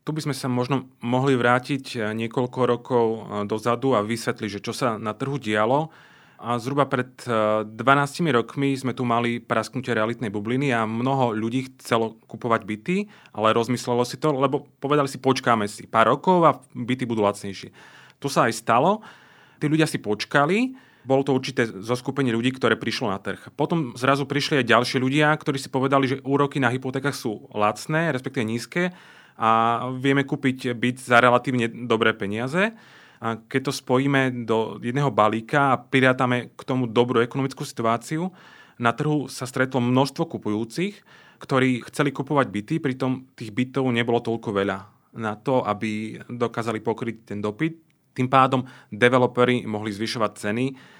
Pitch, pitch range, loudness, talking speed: 125 Hz, 115-140 Hz, -23 LUFS, 160 wpm